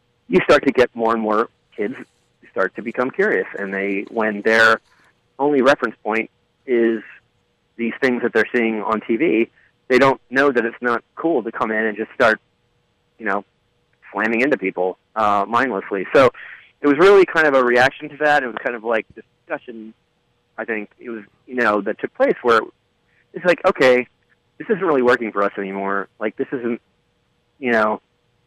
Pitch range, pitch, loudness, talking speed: 110-125 Hz, 115 Hz, -18 LUFS, 185 wpm